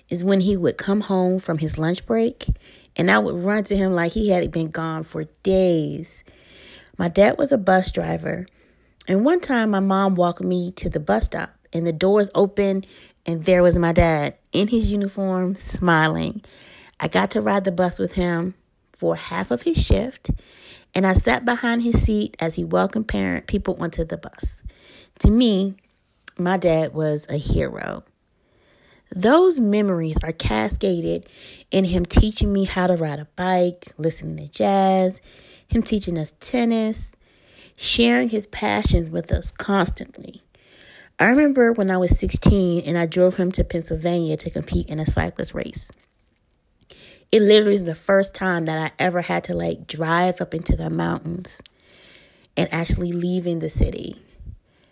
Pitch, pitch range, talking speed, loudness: 180 Hz, 160-195 Hz, 165 wpm, -21 LUFS